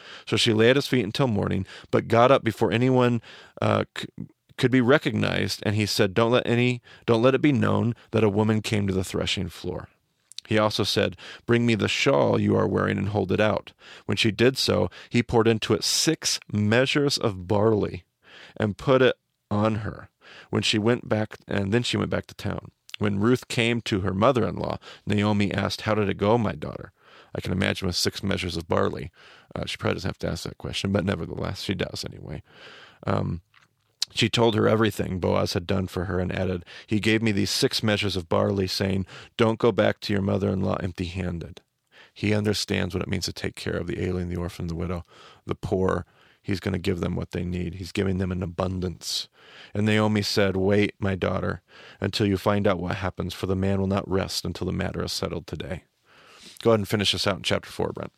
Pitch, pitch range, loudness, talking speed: 105 Hz, 95-110 Hz, -25 LUFS, 220 wpm